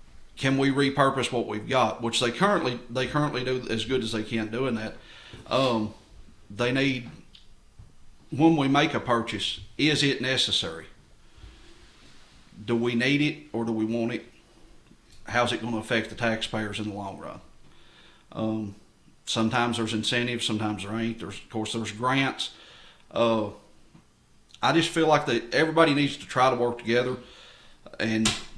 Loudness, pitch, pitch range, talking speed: -26 LUFS, 120 Hz, 110-130 Hz, 160 wpm